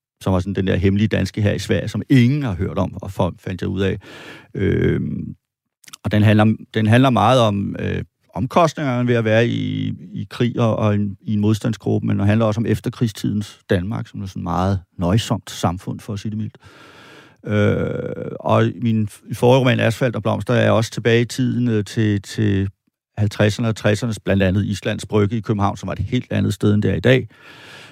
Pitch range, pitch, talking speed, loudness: 100-120 Hz, 110 Hz, 210 wpm, -19 LUFS